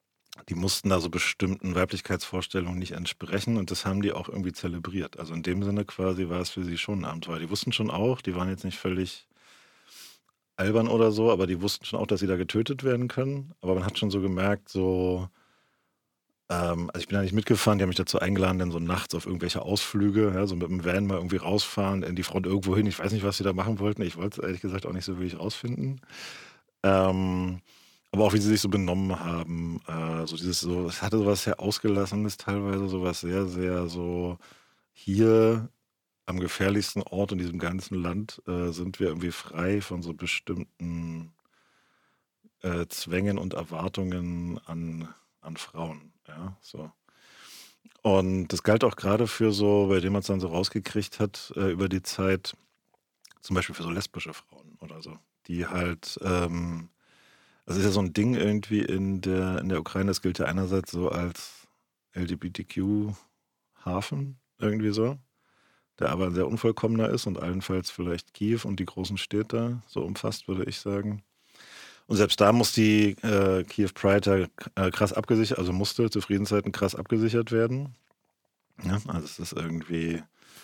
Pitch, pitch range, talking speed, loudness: 95 Hz, 90-105 Hz, 180 wpm, -28 LUFS